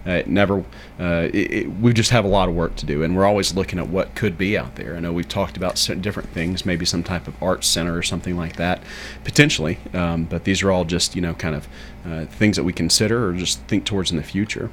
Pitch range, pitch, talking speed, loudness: 85-100 Hz, 90 Hz, 265 wpm, -21 LUFS